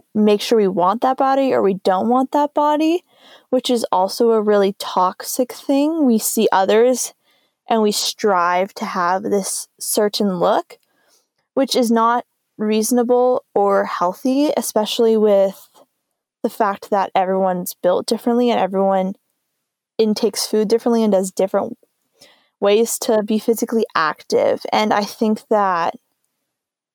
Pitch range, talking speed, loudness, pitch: 195-250 Hz, 135 wpm, -18 LUFS, 220 Hz